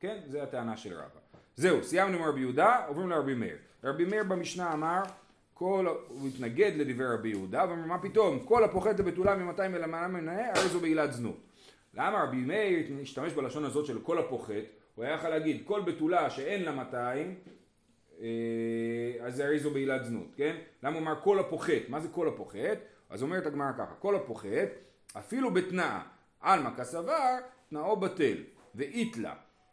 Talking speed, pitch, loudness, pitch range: 170 wpm, 160 Hz, -32 LUFS, 130-190 Hz